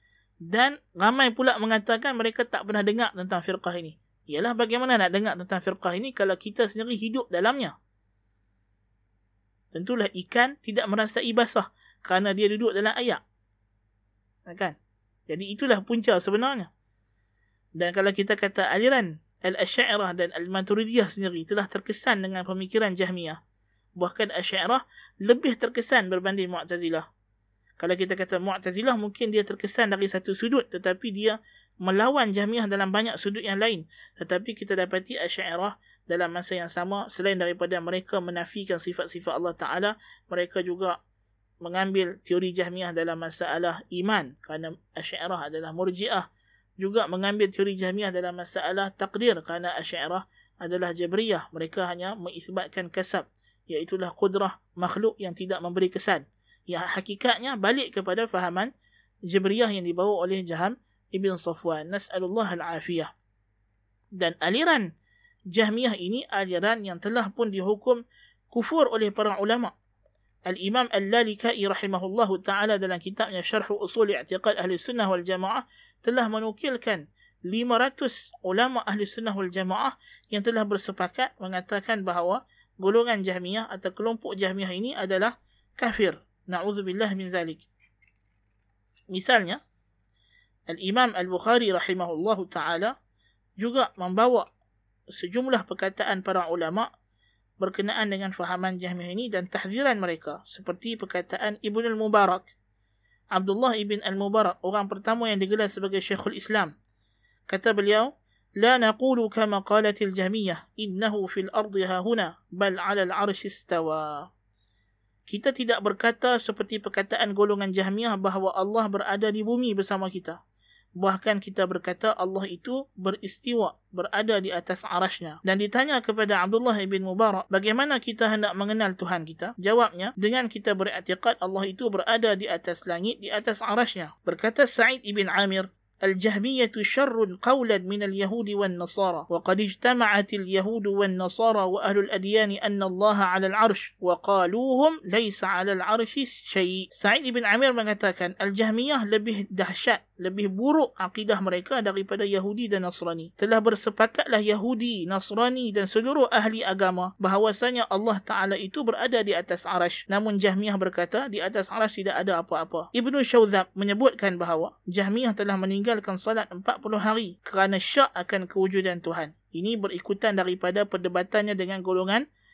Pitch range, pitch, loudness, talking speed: 180-220 Hz, 195 Hz, -26 LUFS, 130 wpm